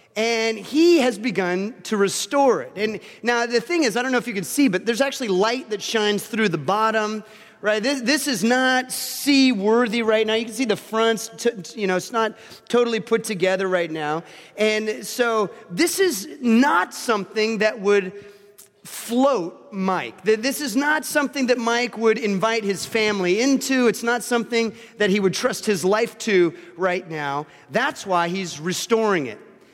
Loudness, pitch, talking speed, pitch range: -21 LUFS, 220 Hz, 180 wpm, 200-240 Hz